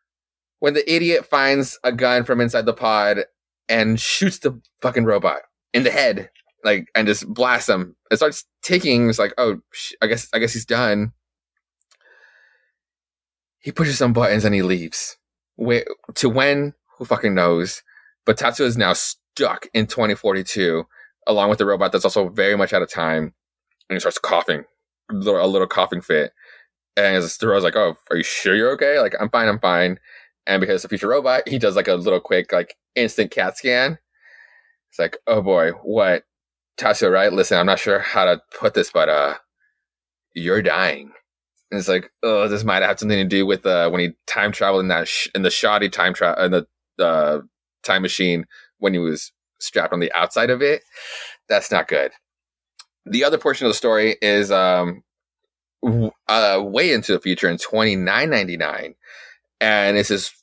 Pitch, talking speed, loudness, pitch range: 110 Hz, 185 wpm, -19 LUFS, 90-140 Hz